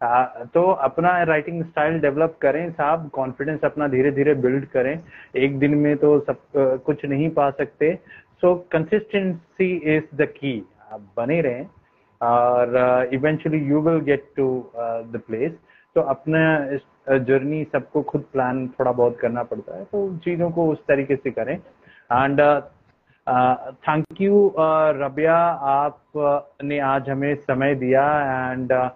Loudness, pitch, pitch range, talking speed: -21 LUFS, 145 Hz, 130-155 Hz, 140 wpm